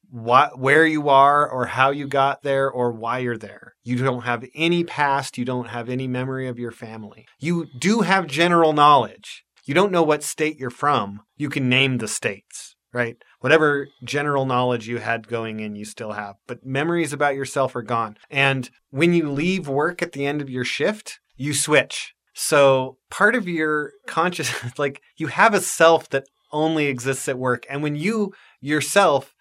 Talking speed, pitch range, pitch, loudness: 190 wpm, 125-155 Hz, 140 Hz, -21 LUFS